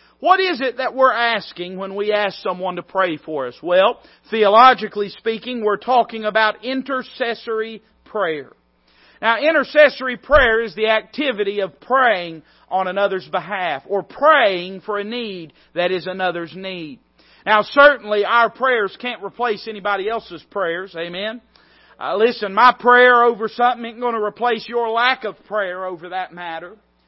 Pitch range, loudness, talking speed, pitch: 185-240 Hz, -18 LUFS, 150 wpm, 215 Hz